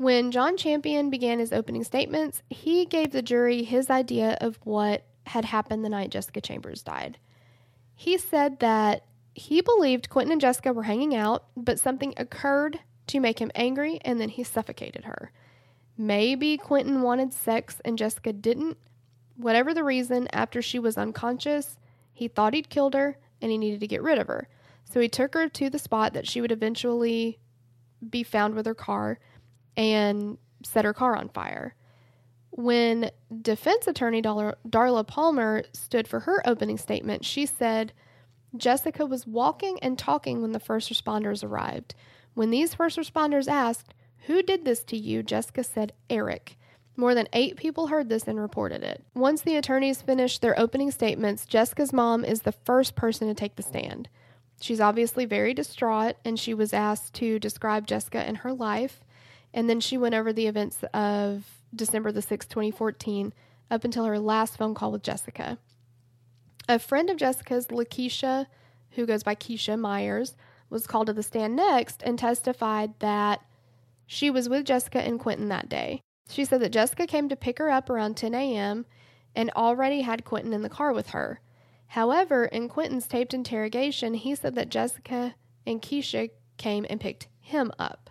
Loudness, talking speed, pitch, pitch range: -27 LUFS, 175 wpm, 230 Hz, 210-260 Hz